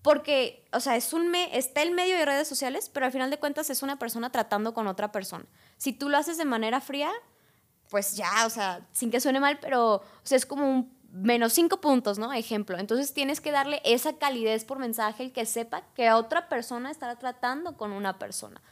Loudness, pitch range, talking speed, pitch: -28 LUFS, 225-285 Hz, 220 wpm, 255 Hz